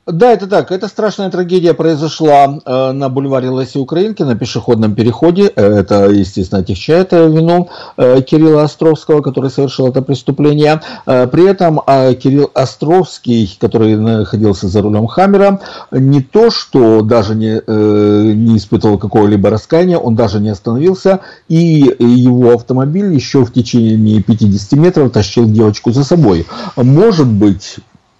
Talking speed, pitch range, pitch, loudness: 135 wpm, 110-160 Hz, 130 Hz, -10 LUFS